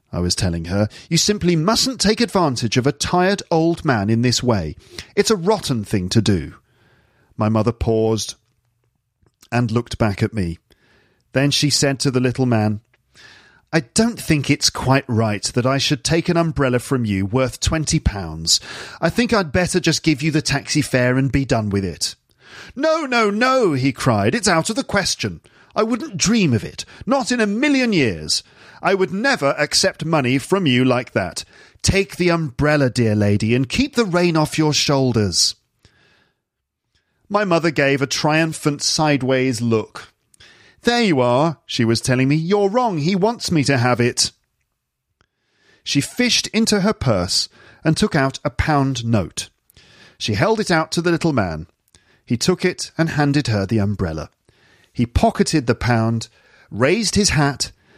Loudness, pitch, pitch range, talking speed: -18 LUFS, 140 Hz, 115-170 Hz, 175 wpm